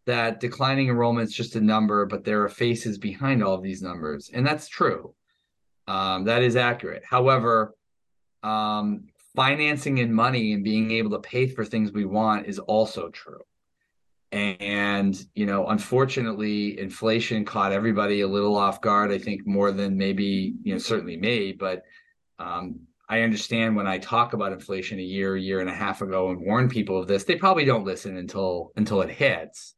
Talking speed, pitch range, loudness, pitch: 180 wpm, 100-120 Hz, -24 LUFS, 105 Hz